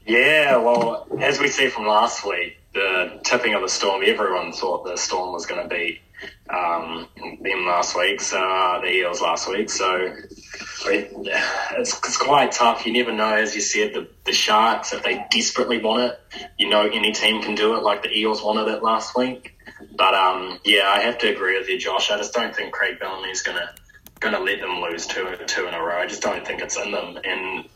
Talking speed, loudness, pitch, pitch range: 220 wpm, -20 LUFS, 110 Hz, 105-120 Hz